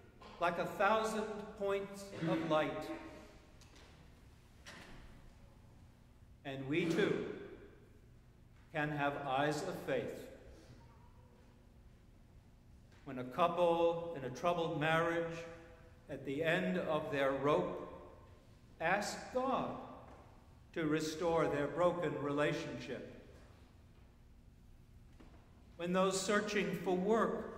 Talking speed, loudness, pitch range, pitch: 85 wpm, -37 LUFS, 145-190 Hz, 165 Hz